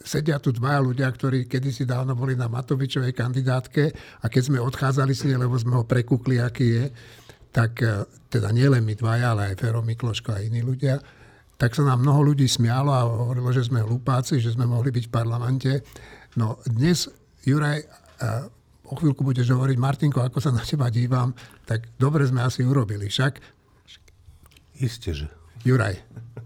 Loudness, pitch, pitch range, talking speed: -23 LUFS, 125 Hz, 115-135 Hz, 165 wpm